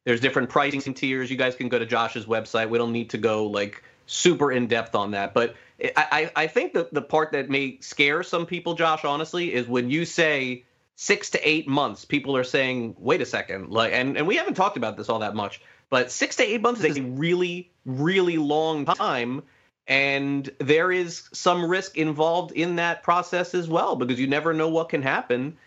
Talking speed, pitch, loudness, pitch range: 210 wpm, 145 Hz, -24 LUFS, 125-170 Hz